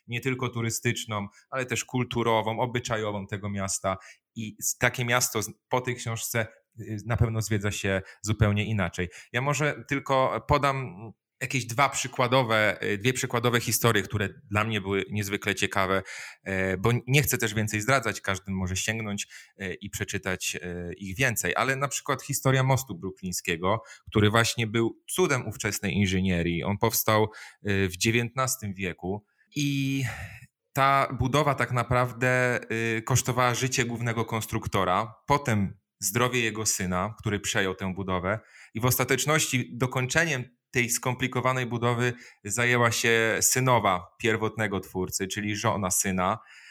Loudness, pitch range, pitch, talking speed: -27 LUFS, 100-125 Hz, 115 Hz, 125 wpm